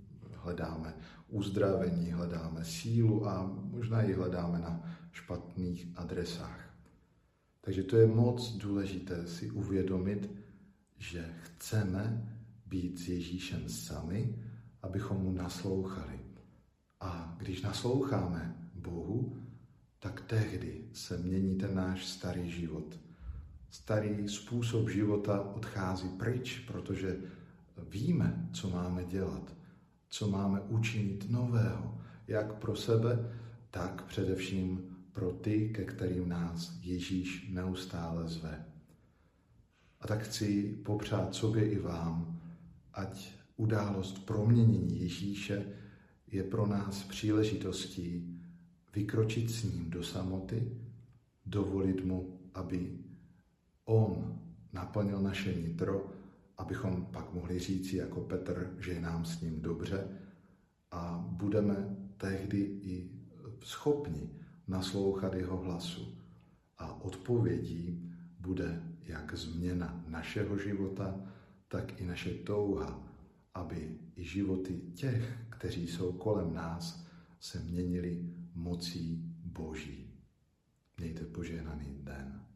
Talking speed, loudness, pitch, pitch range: 100 wpm, -36 LUFS, 95 Hz, 85-105 Hz